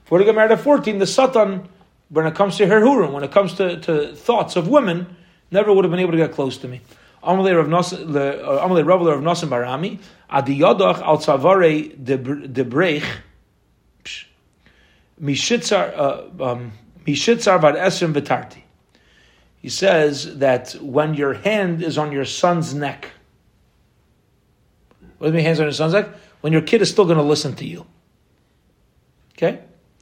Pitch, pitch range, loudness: 165 Hz, 140-190 Hz, -18 LUFS